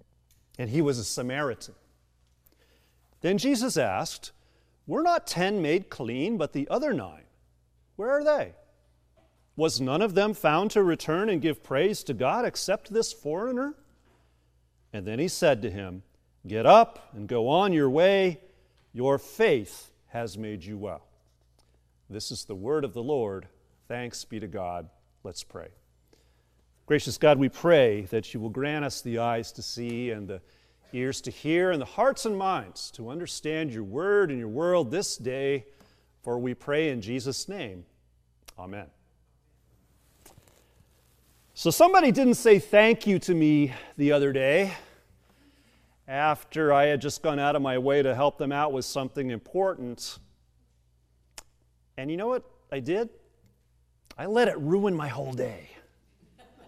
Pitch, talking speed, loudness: 125 Hz, 155 wpm, -26 LUFS